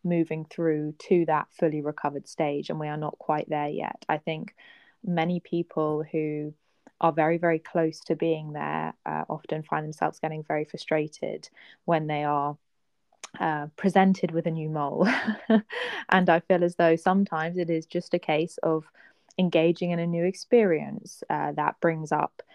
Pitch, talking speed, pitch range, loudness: 165 Hz, 170 wpm, 155-175 Hz, -27 LUFS